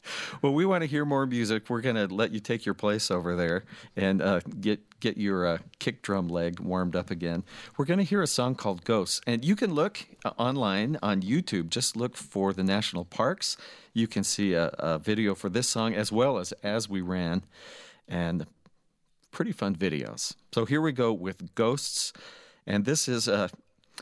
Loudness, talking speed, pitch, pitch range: -29 LUFS, 200 wpm, 105 Hz, 95-120 Hz